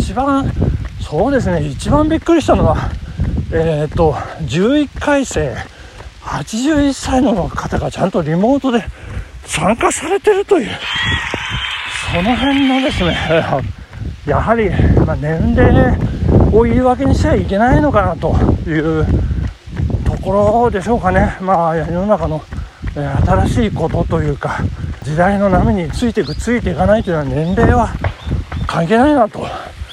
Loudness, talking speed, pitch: -15 LUFS, 265 characters per minute, 185 Hz